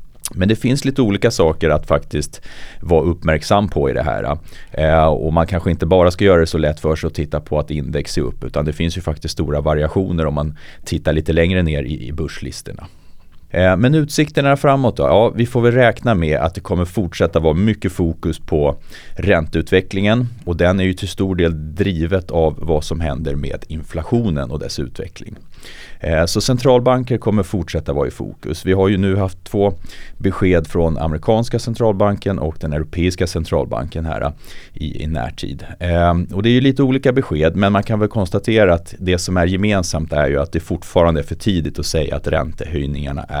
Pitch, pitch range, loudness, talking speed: 85 Hz, 80-100 Hz, -17 LUFS, 195 wpm